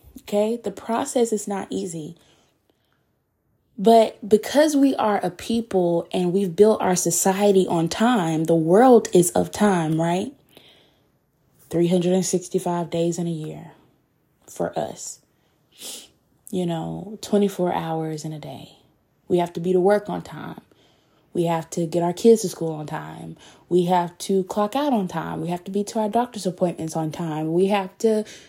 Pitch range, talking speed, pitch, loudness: 165-210 Hz, 160 wpm, 180 Hz, -22 LUFS